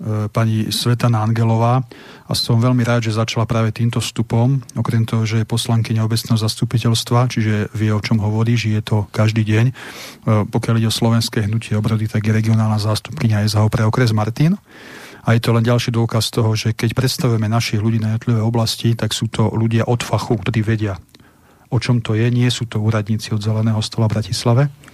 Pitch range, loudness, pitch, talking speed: 110-120 Hz, -18 LUFS, 115 Hz, 190 wpm